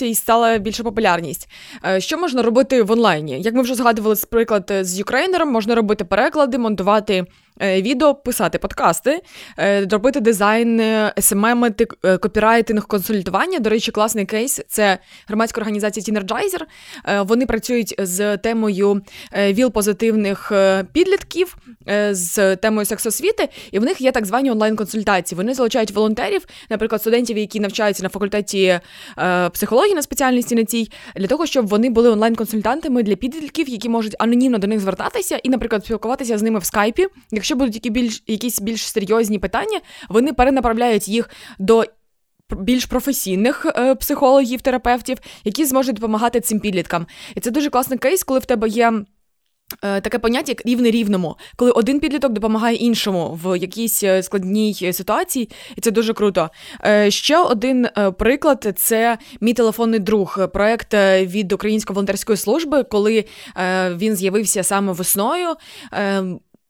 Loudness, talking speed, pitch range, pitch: -18 LUFS, 140 wpm, 205-245 Hz, 225 Hz